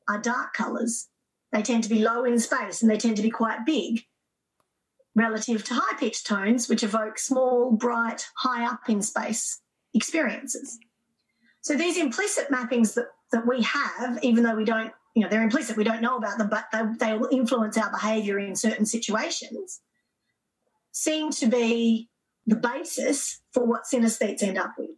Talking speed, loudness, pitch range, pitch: 175 wpm, -25 LUFS, 220-250 Hz, 230 Hz